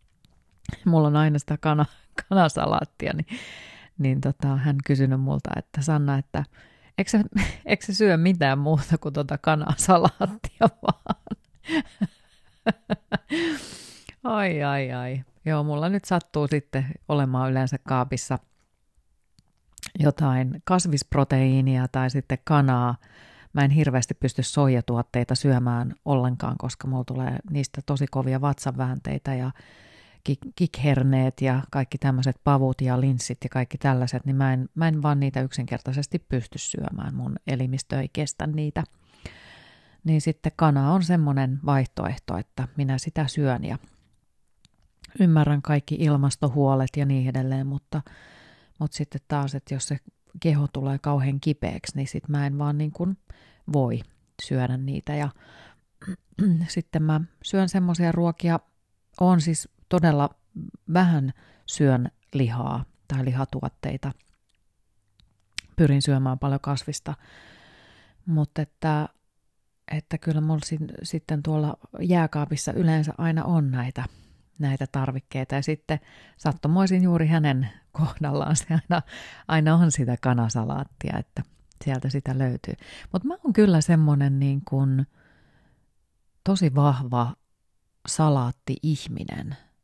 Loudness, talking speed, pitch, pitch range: -25 LUFS, 120 wpm, 145 Hz, 130-155 Hz